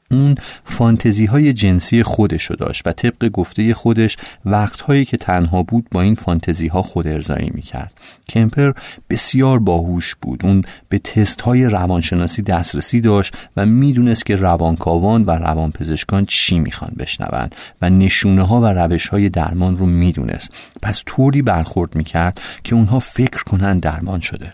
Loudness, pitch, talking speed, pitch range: -16 LUFS, 95 Hz, 150 wpm, 85-115 Hz